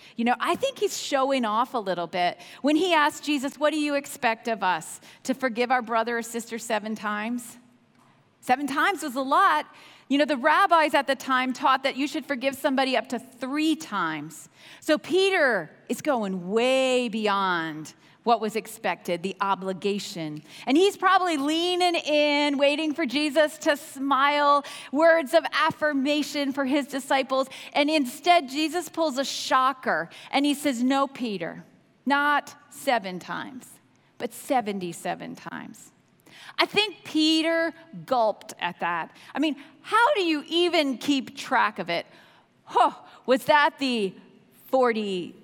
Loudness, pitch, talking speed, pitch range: -25 LUFS, 275 Hz, 155 wpm, 230-305 Hz